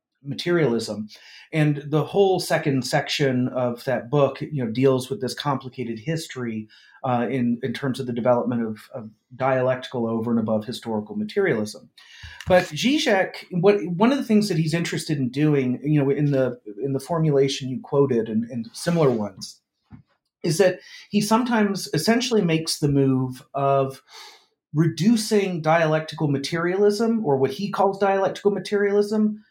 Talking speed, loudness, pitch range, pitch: 150 wpm, -22 LUFS, 125-190 Hz, 145 Hz